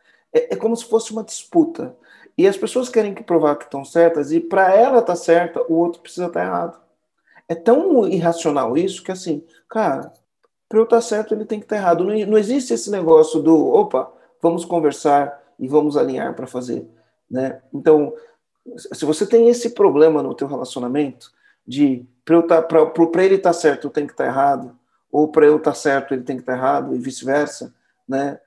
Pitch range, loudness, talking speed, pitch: 150-215 Hz, -18 LUFS, 200 wpm, 170 Hz